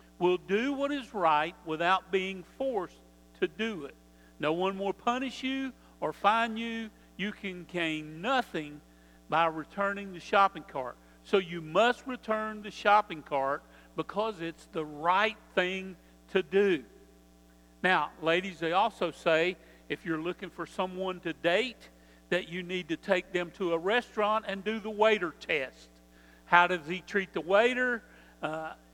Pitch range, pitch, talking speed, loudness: 155-205 Hz, 180 Hz, 155 wpm, -30 LUFS